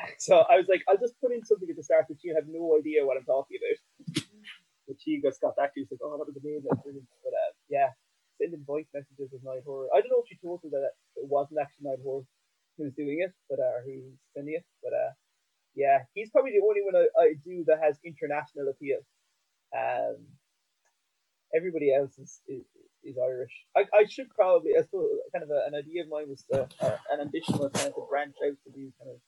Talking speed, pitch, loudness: 225 wpm, 160 Hz, -29 LUFS